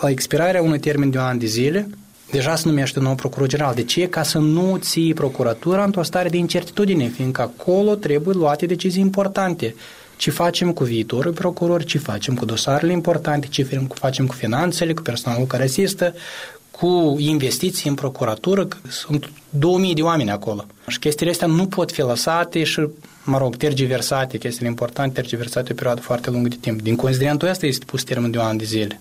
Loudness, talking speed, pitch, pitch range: -20 LUFS, 190 wpm, 145 Hz, 125-175 Hz